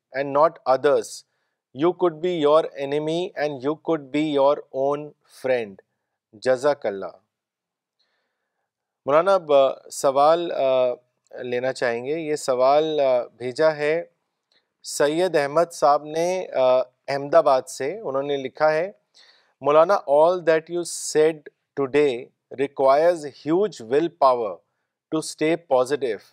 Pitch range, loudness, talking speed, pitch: 140-170 Hz, -22 LUFS, 110 wpm, 150 Hz